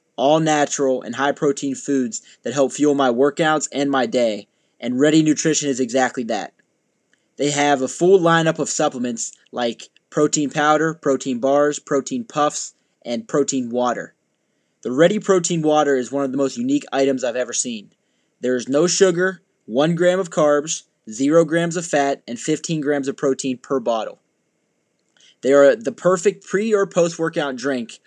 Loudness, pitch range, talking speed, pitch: -19 LUFS, 135-165 Hz, 170 wpm, 145 Hz